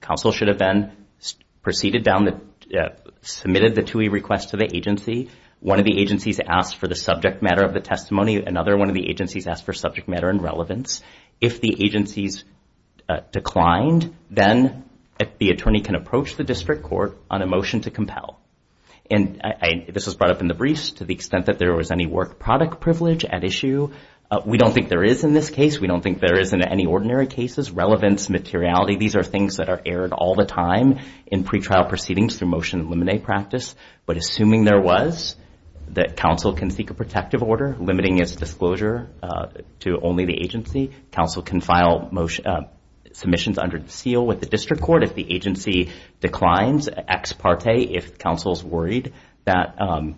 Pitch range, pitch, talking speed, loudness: 90-110 Hz, 100 Hz, 190 wpm, -21 LUFS